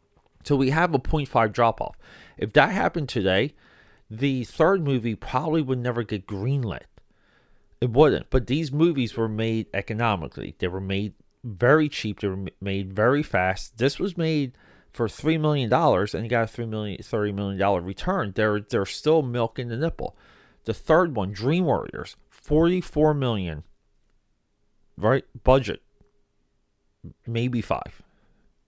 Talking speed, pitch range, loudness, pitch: 145 wpm, 100-140 Hz, -24 LUFS, 115 Hz